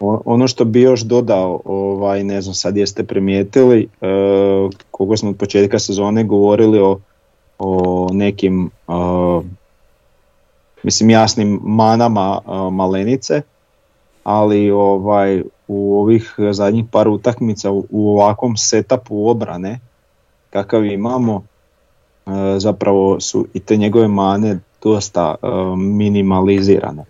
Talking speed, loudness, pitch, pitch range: 110 wpm, -15 LUFS, 100 Hz, 95-110 Hz